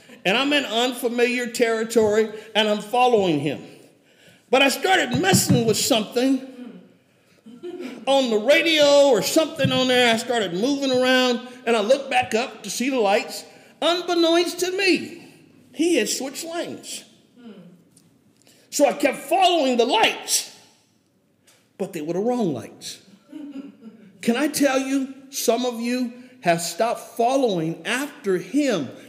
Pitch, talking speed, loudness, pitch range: 250 Hz, 135 wpm, -21 LUFS, 225-280 Hz